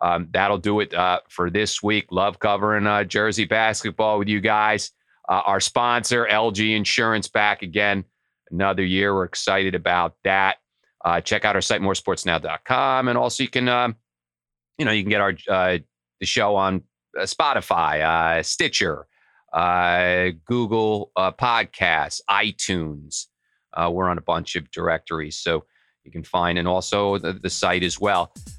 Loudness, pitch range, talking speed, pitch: -21 LUFS, 90-105 Hz, 160 wpm, 95 Hz